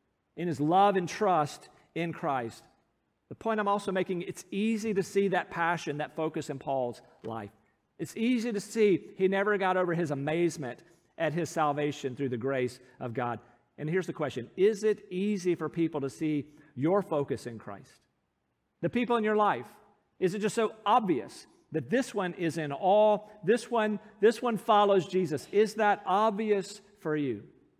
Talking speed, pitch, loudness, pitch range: 180 wpm, 180 Hz, -30 LUFS, 150-205 Hz